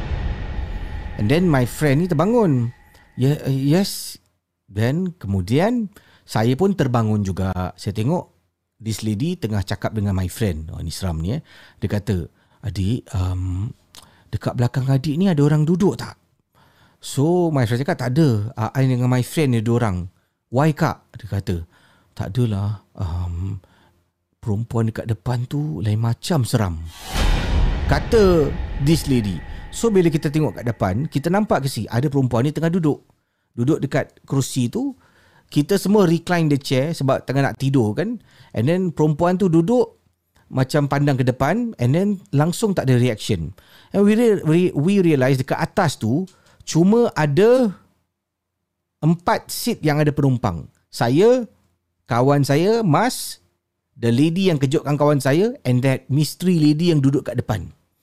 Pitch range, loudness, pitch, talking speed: 100-160 Hz, -20 LUFS, 130 Hz, 155 wpm